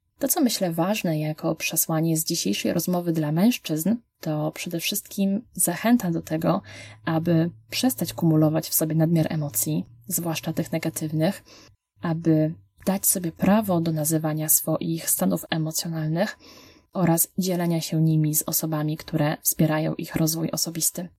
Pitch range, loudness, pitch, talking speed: 155-175 Hz, -24 LUFS, 165 Hz, 135 wpm